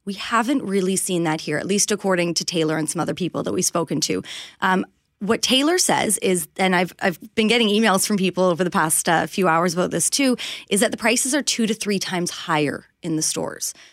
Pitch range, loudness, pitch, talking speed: 170-220 Hz, -20 LUFS, 185 Hz, 235 wpm